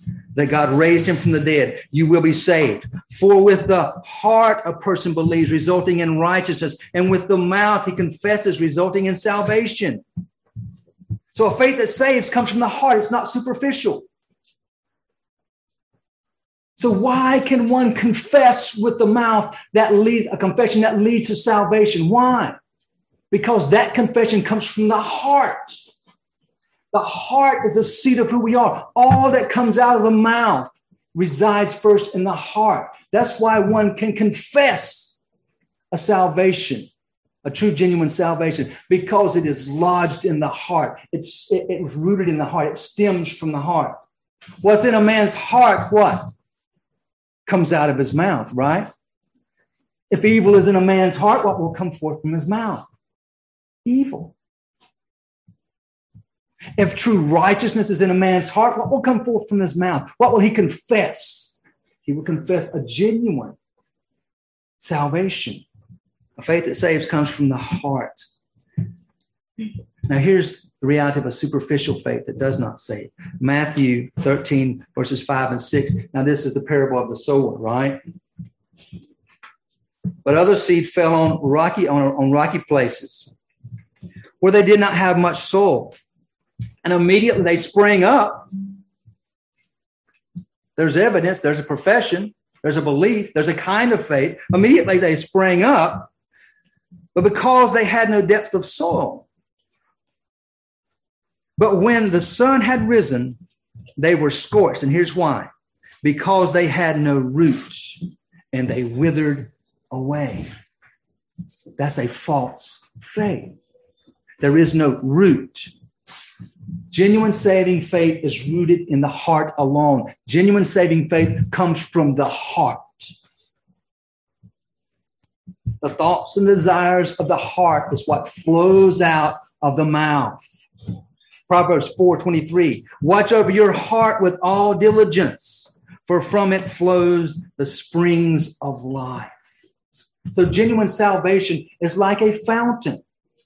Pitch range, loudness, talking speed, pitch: 155-210 Hz, -17 LUFS, 140 wpm, 180 Hz